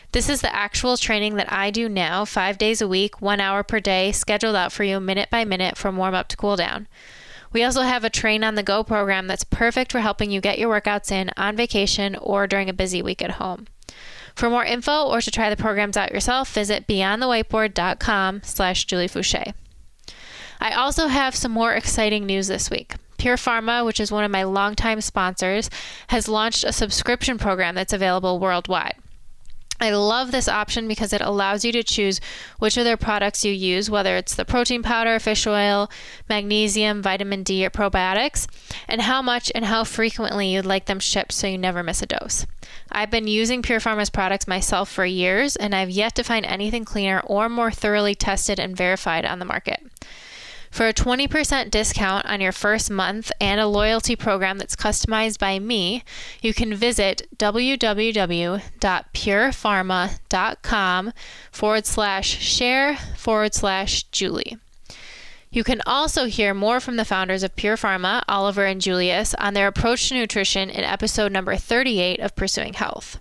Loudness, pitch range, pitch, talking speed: -21 LUFS, 195-230 Hz, 210 Hz, 175 wpm